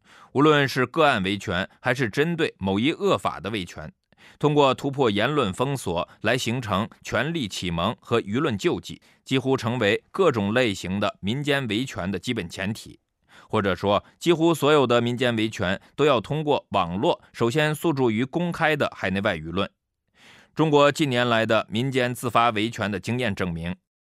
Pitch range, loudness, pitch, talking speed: 100-140 Hz, -23 LUFS, 120 Hz, 260 characters per minute